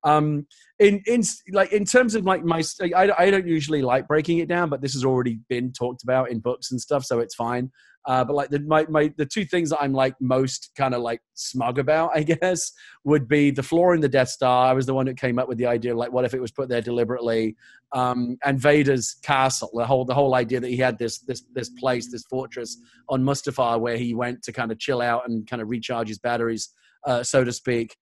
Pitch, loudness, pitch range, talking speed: 130 Hz, -23 LUFS, 120-150 Hz, 245 wpm